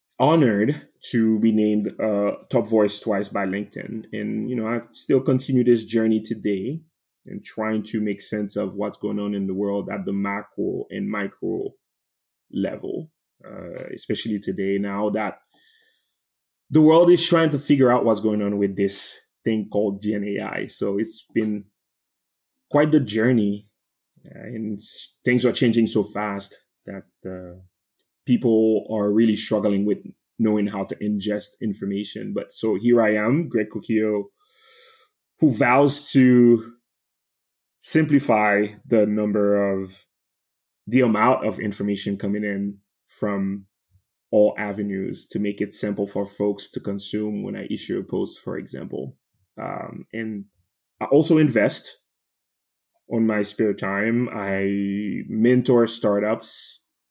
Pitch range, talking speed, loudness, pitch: 100-120 Hz, 140 wpm, -22 LUFS, 105 Hz